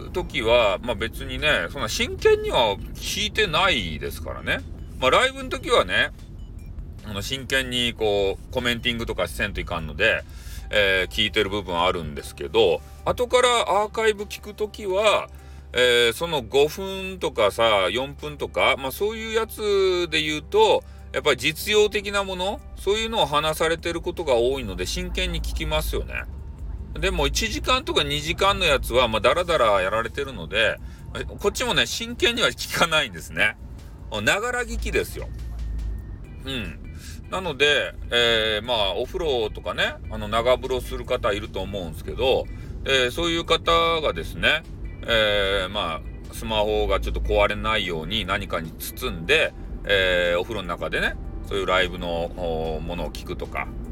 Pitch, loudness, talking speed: 120 Hz, -23 LUFS, 320 characters per minute